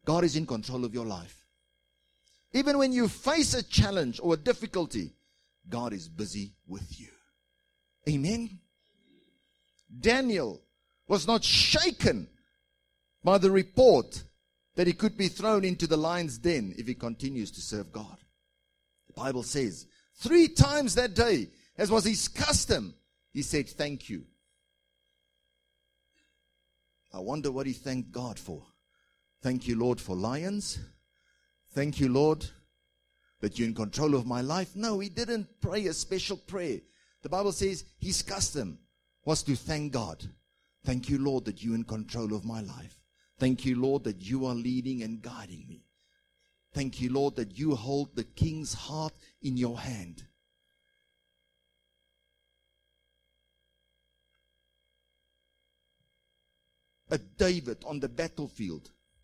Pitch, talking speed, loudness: 115 Hz, 135 wpm, -29 LUFS